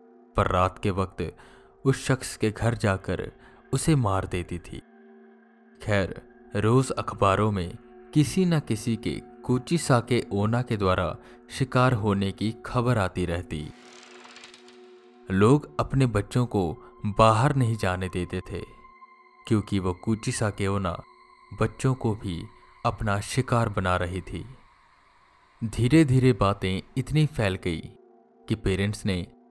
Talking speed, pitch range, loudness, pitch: 130 wpm, 95-125 Hz, -26 LUFS, 110 Hz